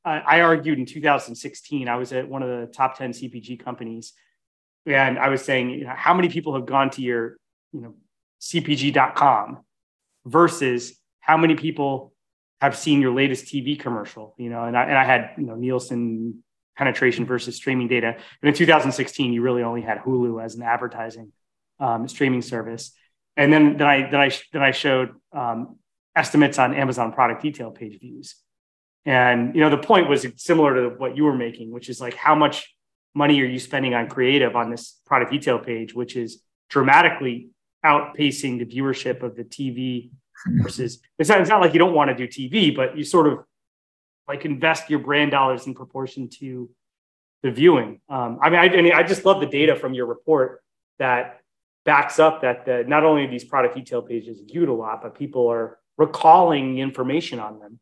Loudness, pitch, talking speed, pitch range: -20 LUFS, 130 Hz, 190 wpm, 120-145 Hz